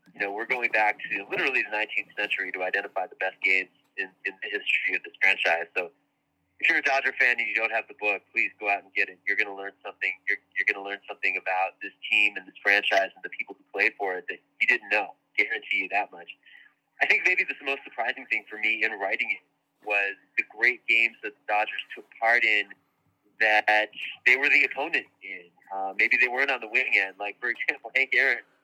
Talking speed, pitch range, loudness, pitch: 235 wpm, 95-105 Hz, -25 LUFS, 100 Hz